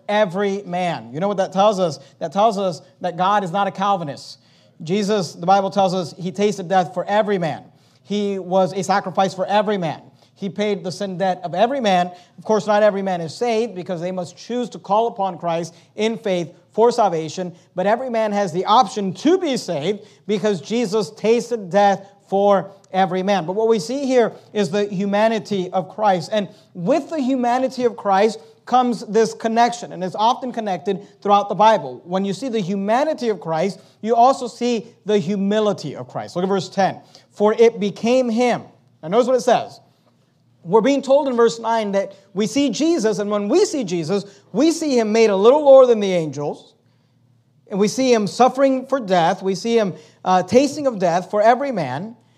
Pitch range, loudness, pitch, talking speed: 185-225 Hz, -19 LUFS, 200 Hz, 200 wpm